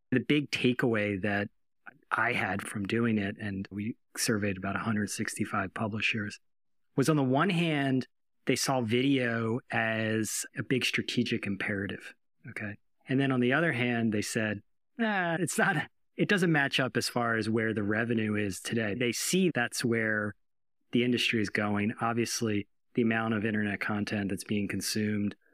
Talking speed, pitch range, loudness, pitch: 160 wpm, 105-130 Hz, -30 LUFS, 115 Hz